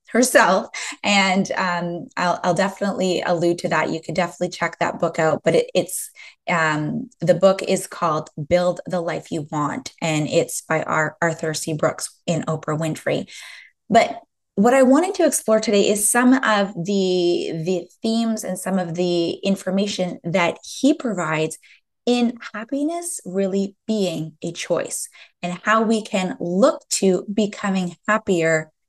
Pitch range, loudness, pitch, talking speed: 170-215 Hz, -21 LUFS, 185 Hz, 155 wpm